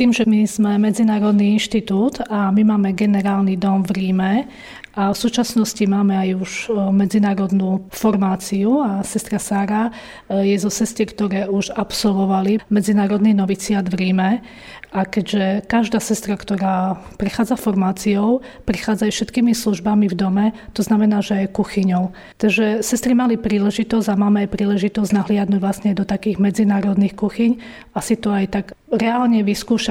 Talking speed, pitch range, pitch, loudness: 145 wpm, 195-220 Hz, 205 Hz, -18 LUFS